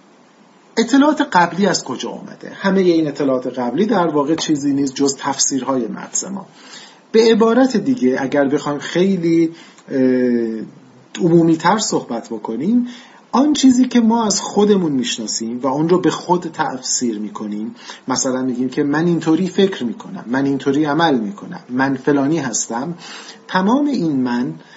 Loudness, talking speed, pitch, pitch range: -17 LUFS, 140 wpm, 165 Hz, 135-210 Hz